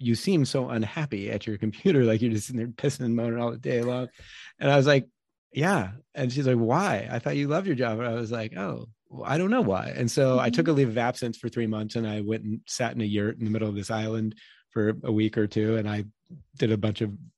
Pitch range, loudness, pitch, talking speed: 110-130 Hz, -27 LUFS, 115 Hz, 275 wpm